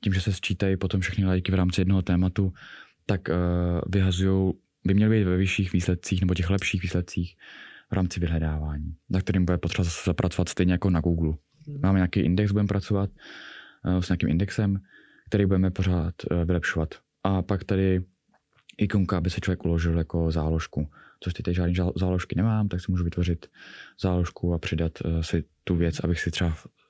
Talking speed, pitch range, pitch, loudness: 170 wpm, 85-95 Hz, 90 Hz, -26 LUFS